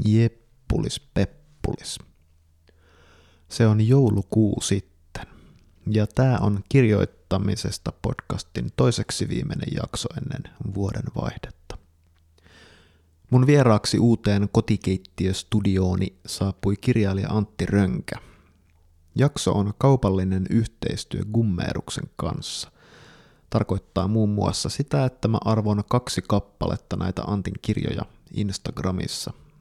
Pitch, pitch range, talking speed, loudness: 105 Hz, 95-115 Hz, 90 wpm, -24 LUFS